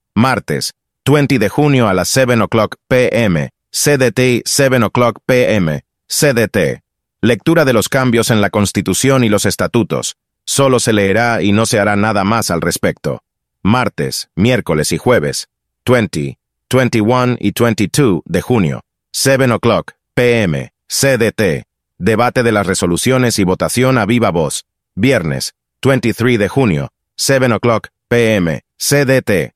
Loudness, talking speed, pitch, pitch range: -13 LUFS, 135 wpm, 115 Hz, 100-130 Hz